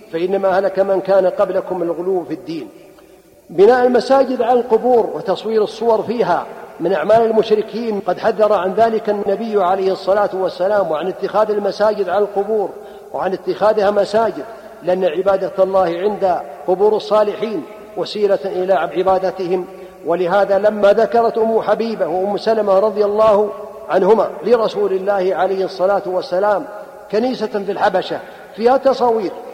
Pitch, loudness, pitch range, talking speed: 205 Hz, -16 LUFS, 185-215 Hz, 130 wpm